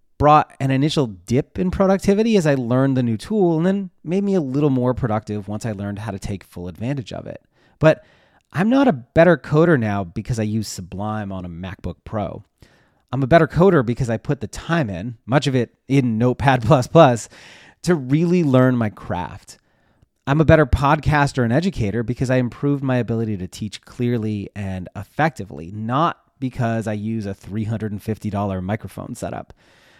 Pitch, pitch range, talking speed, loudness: 125 Hz, 105-150 Hz, 180 wpm, -20 LUFS